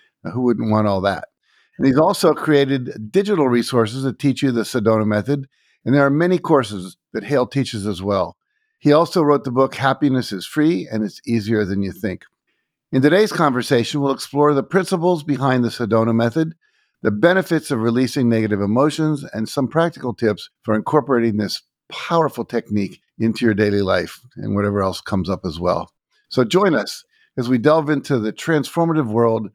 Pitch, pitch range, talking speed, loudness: 130 Hz, 110-150 Hz, 180 wpm, -19 LUFS